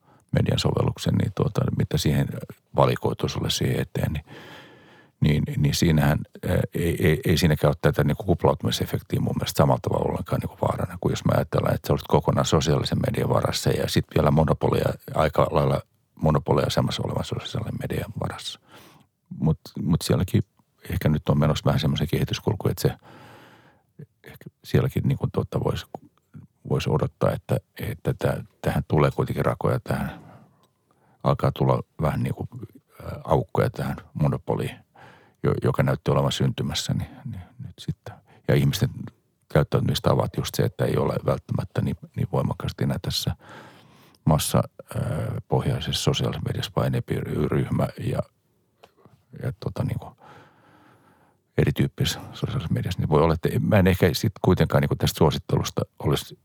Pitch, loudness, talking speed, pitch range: 80 Hz, -24 LUFS, 145 wpm, 75-110 Hz